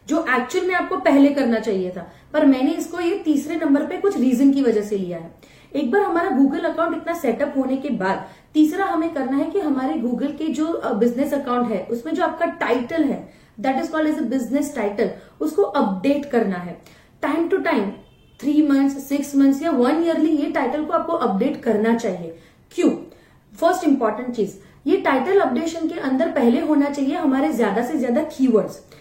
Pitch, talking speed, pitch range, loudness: 280 Hz, 195 wpm, 240-320 Hz, -20 LUFS